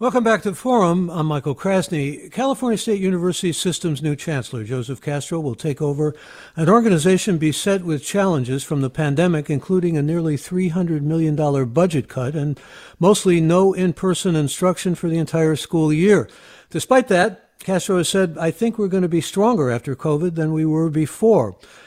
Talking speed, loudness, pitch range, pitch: 170 wpm, -19 LUFS, 150-190 Hz, 170 Hz